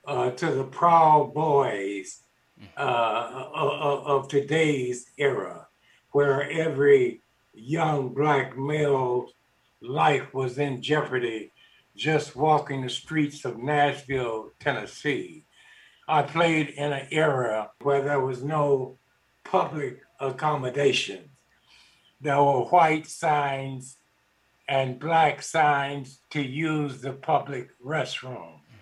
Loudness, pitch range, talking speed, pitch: -25 LUFS, 130-150 Hz, 100 wpm, 140 Hz